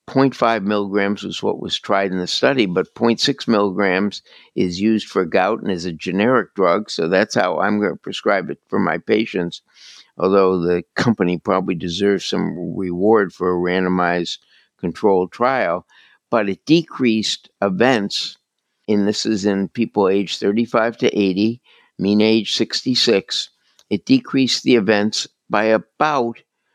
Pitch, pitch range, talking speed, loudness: 100 Hz, 95-110 Hz, 150 wpm, -18 LUFS